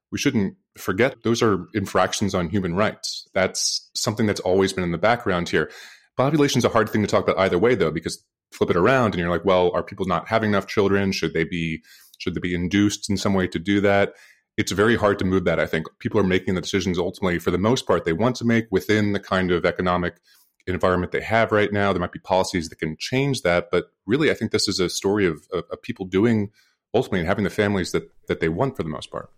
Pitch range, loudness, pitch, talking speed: 90-105 Hz, -22 LUFS, 95 Hz, 245 wpm